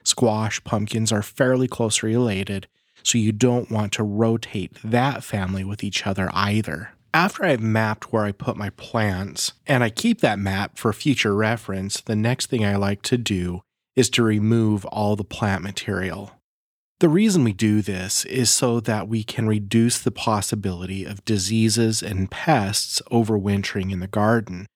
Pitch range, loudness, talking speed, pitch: 100-120 Hz, -22 LUFS, 165 wpm, 110 Hz